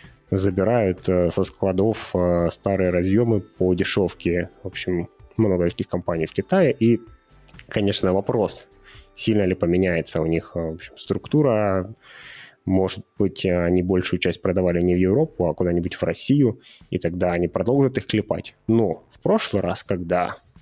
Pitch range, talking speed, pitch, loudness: 90-105 Hz, 145 wpm, 95 Hz, -22 LUFS